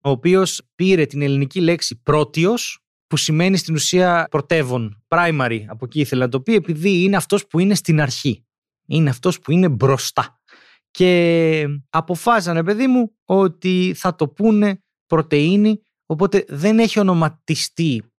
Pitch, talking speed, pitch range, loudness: 165 Hz, 145 wpm, 145-190 Hz, -18 LUFS